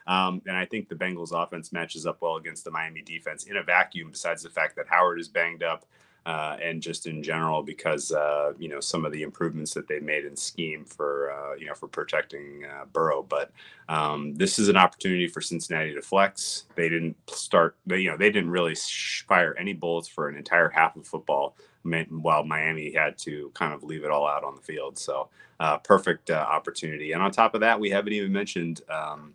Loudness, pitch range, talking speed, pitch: -27 LUFS, 75-90 Hz, 215 wpm, 80 Hz